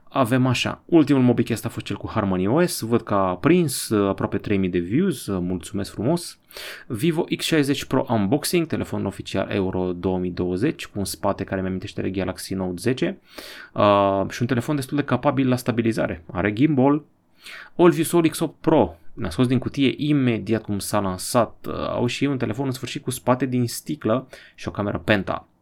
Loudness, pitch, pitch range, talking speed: -22 LUFS, 120 Hz, 100-145 Hz, 180 wpm